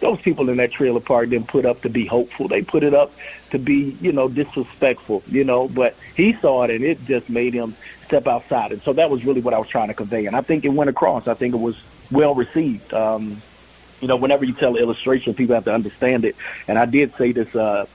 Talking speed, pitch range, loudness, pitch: 255 wpm, 115-140 Hz, -19 LUFS, 125 Hz